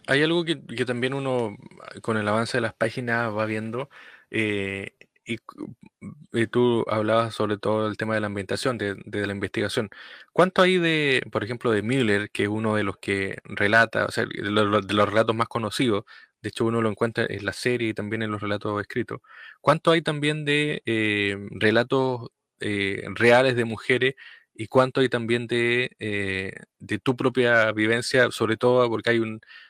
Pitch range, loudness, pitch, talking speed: 105-125 Hz, -24 LUFS, 115 Hz, 185 wpm